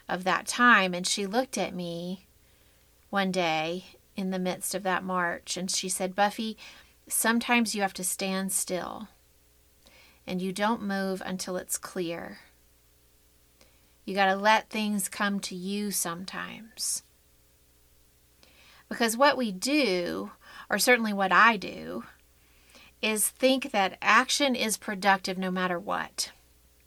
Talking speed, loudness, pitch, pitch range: 135 wpm, -27 LUFS, 185 Hz, 155-210 Hz